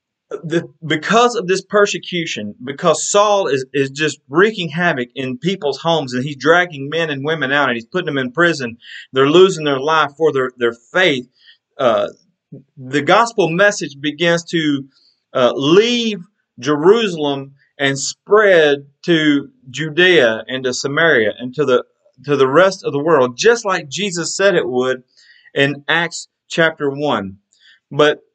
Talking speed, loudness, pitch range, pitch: 150 wpm, -16 LUFS, 135-180 Hz, 155 Hz